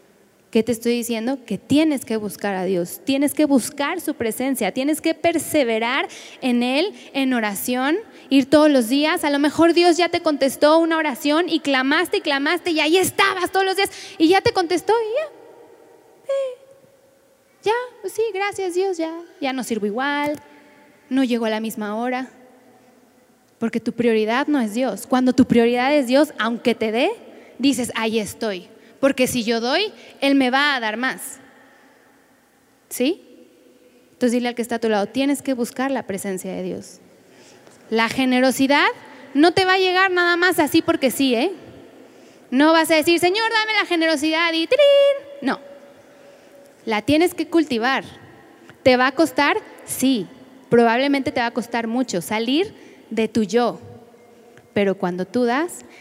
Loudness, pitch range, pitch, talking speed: -20 LUFS, 240-325 Hz, 275 Hz, 170 wpm